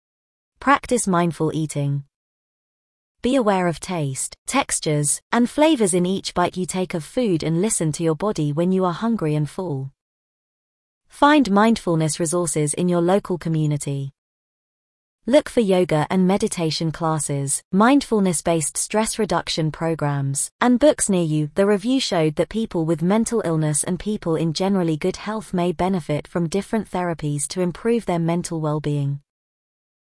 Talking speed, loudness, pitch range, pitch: 150 wpm, -21 LUFS, 155-210 Hz, 175 Hz